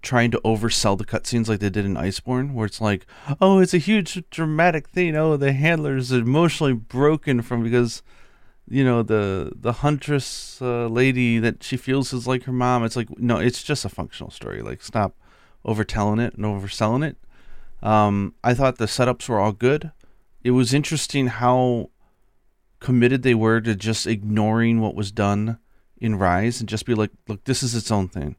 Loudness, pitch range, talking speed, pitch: -21 LUFS, 110-130 Hz, 190 wpm, 120 Hz